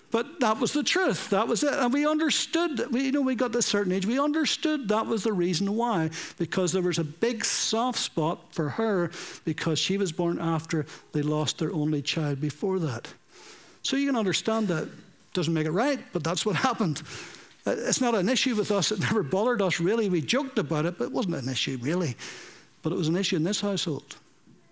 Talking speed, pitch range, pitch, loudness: 220 wpm, 165-245 Hz, 200 Hz, -27 LUFS